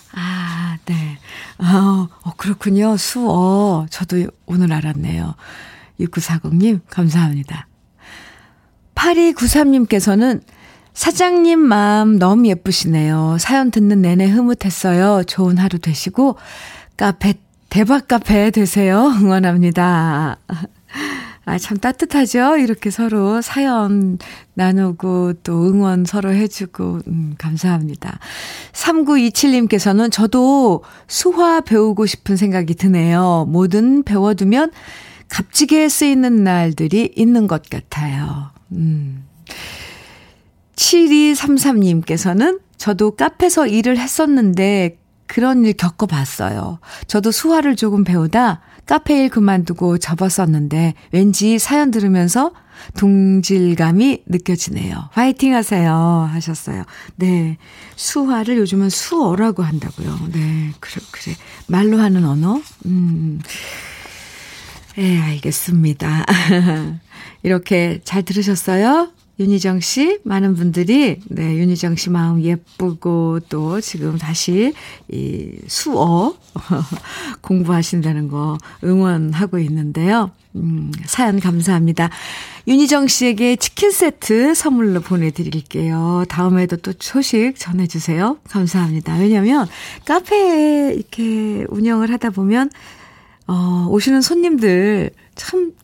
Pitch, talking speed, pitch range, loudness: 190 Hz, 230 characters per minute, 170-230 Hz, -15 LUFS